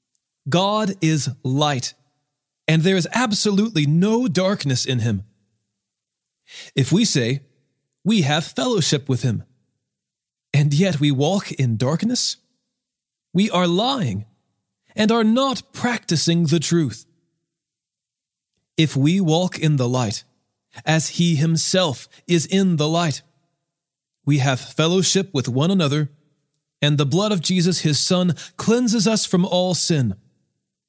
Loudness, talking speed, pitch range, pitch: -19 LUFS, 125 wpm, 140-185 Hz, 160 Hz